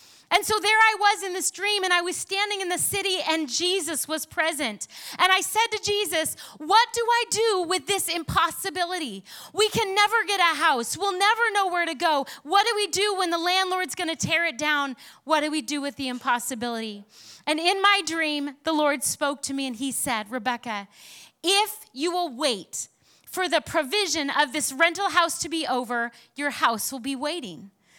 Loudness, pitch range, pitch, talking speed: -24 LUFS, 280-390 Hz, 335 Hz, 200 wpm